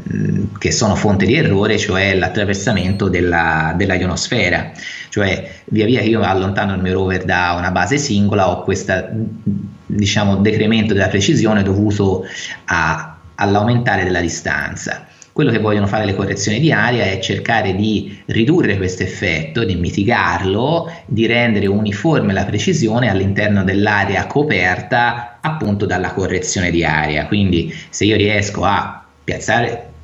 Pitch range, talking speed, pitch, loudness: 95-110 Hz, 140 wpm, 100 Hz, -16 LUFS